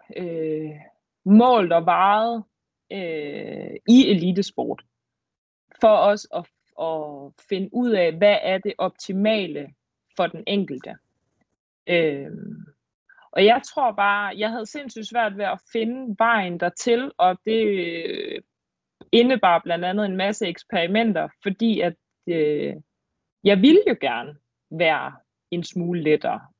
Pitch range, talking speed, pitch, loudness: 170-225 Hz, 125 wpm, 200 Hz, -21 LUFS